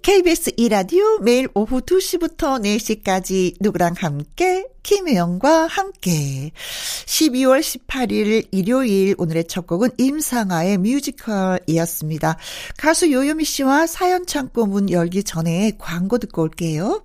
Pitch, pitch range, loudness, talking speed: 225 Hz, 180-300 Hz, -19 LUFS, 255 characters per minute